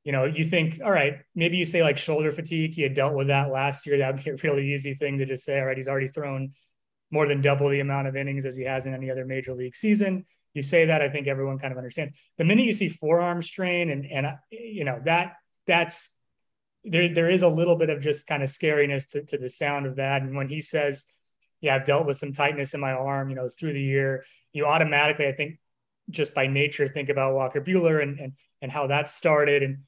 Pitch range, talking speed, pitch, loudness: 135-160 Hz, 245 wpm, 145 Hz, -25 LUFS